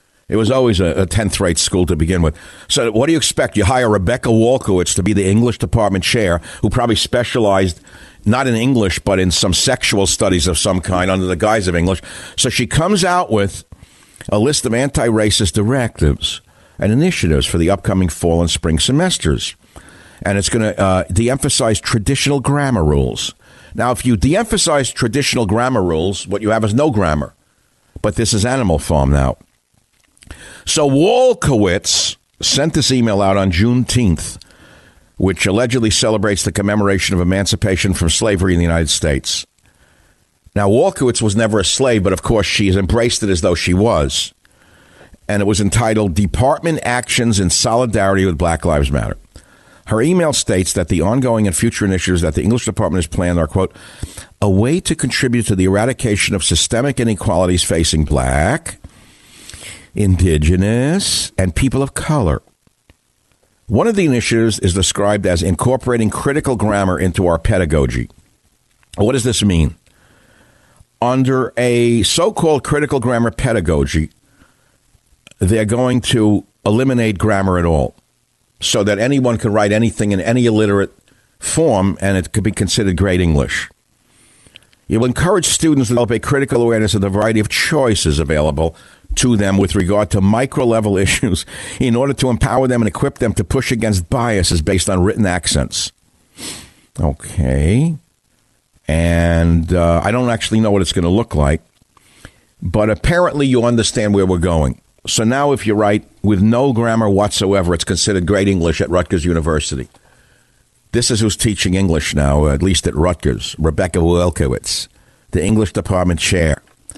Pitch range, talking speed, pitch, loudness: 90-120 Hz, 160 wpm, 105 Hz, -15 LUFS